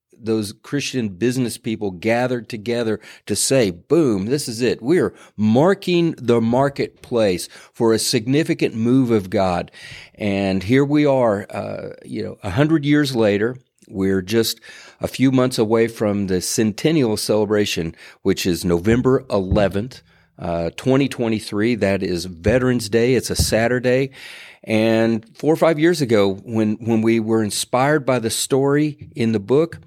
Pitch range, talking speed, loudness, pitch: 105-130 Hz, 145 wpm, -19 LUFS, 115 Hz